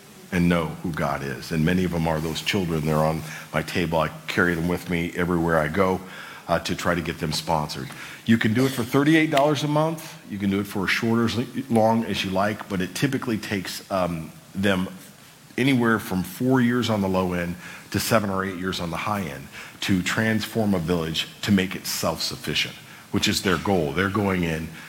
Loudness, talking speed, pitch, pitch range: -24 LUFS, 220 wpm, 95 Hz, 85-110 Hz